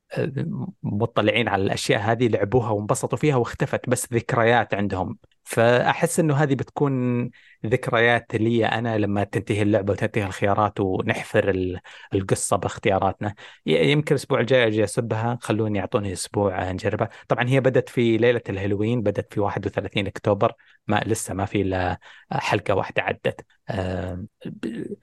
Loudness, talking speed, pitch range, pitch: -23 LUFS, 130 wpm, 100-125 Hz, 110 Hz